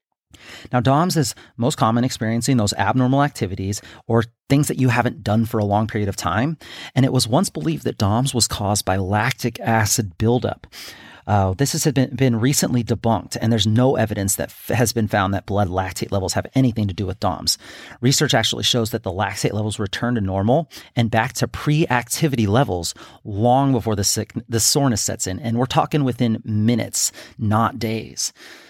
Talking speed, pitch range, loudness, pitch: 190 wpm, 105-125 Hz, -20 LUFS, 115 Hz